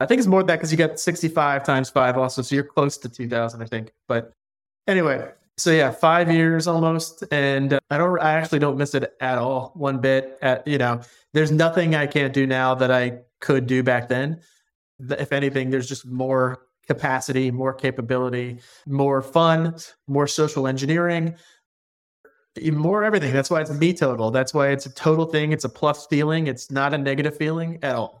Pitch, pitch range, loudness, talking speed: 140 Hz, 130-160 Hz, -21 LUFS, 195 wpm